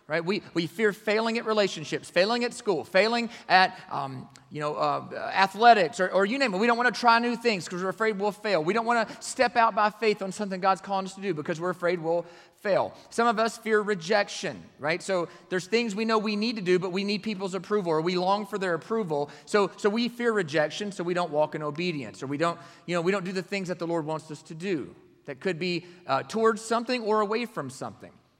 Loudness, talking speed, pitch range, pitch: -27 LUFS, 250 wpm, 170-220 Hz, 195 Hz